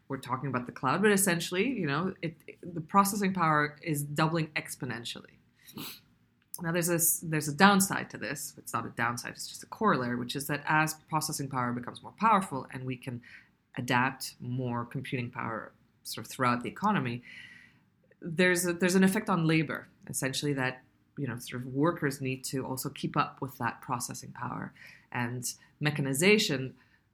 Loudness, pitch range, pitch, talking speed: -30 LUFS, 130-170 Hz, 145 Hz, 175 wpm